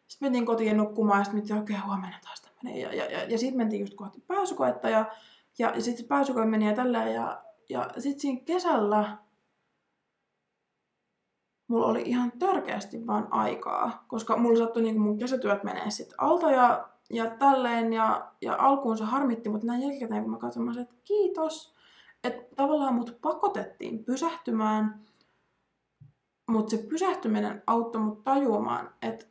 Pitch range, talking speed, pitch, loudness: 215-275 Hz, 160 wpm, 230 Hz, -28 LUFS